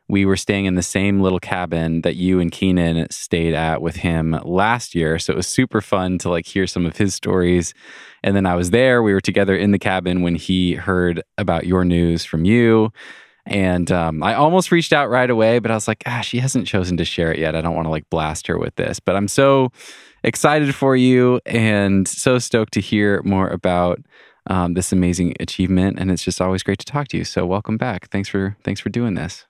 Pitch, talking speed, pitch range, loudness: 95 Hz, 230 wpm, 90-110 Hz, -18 LUFS